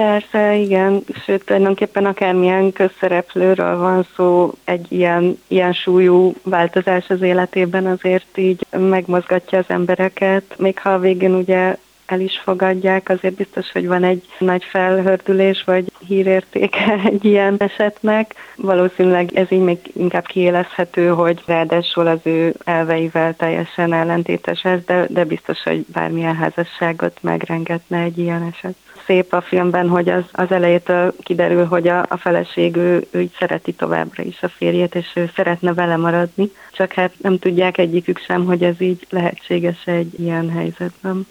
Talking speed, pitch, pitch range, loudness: 150 wpm, 180 Hz, 175-190 Hz, -17 LUFS